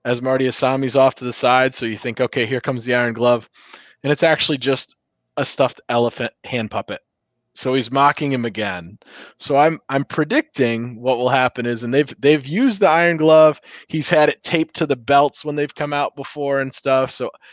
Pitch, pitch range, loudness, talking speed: 135 Hz, 125-150 Hz, -18 LUFS, 205 wpm